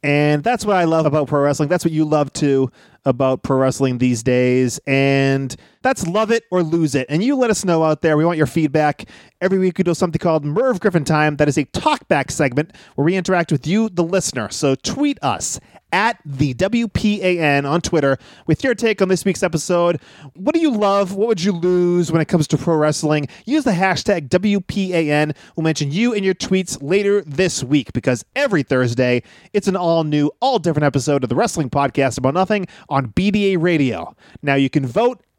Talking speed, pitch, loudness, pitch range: 205 wpm, 165 Hz, -18 LUFS, 145-190 Hz